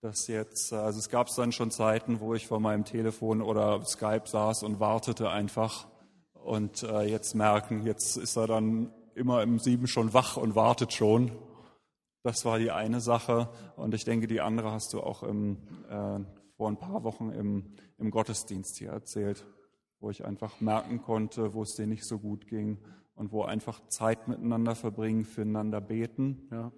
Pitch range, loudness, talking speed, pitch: 105-115 Hz, -31 LUFS, 175 wpm, 110 Hz